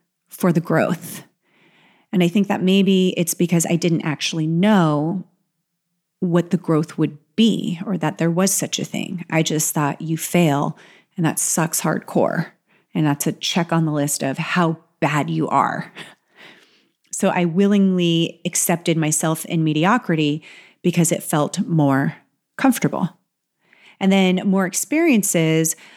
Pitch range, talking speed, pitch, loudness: 160-185 Hz, 145 wpm, 170 Hz, -19 LUFS